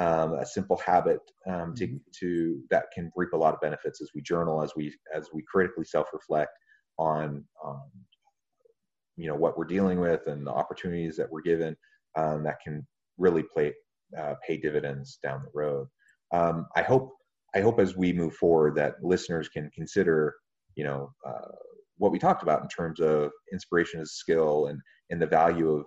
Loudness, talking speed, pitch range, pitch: -28 LUFS, 185 wpm, 75-90 Hz, 85 Hz